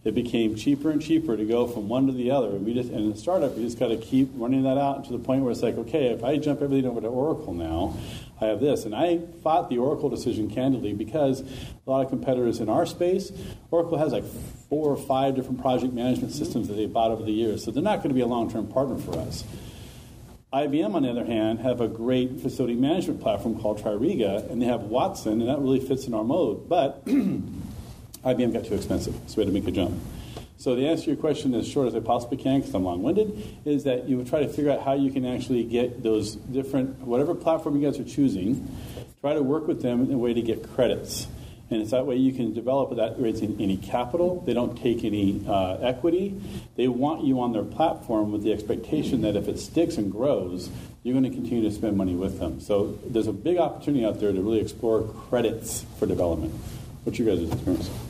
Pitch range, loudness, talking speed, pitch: 110-135 Hz, -26 LUFS, 235 wpm, 125 Hz